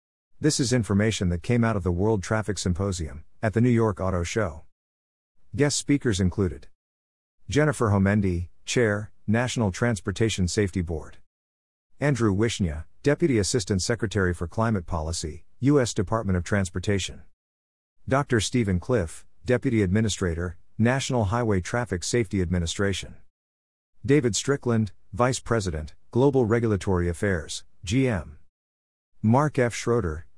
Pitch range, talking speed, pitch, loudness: 85-115 Hz, 120 wpm, 100 Hz, -25 LUFS